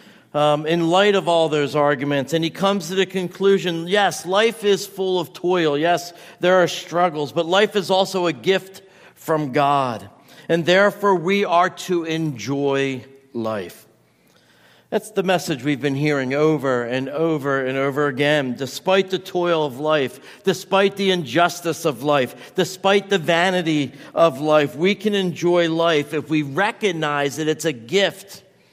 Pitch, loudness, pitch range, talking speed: 170 Hz, -20 LUFS, 150-190 Hz, 160 wpm